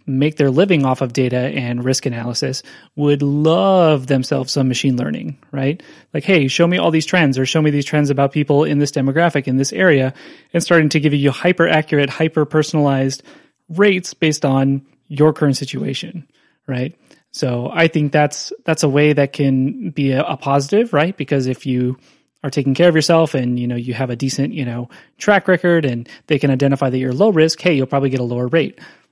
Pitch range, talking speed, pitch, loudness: 135-160 Hz, 205 wpm, 145 Hz, -16 LUFS